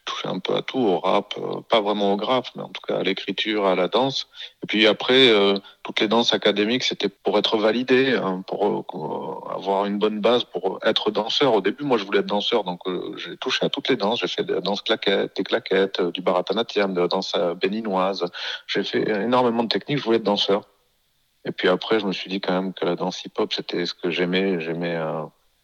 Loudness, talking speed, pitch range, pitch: -22 LUFS, 235 wpm, 95-110 Hz, 100 Hz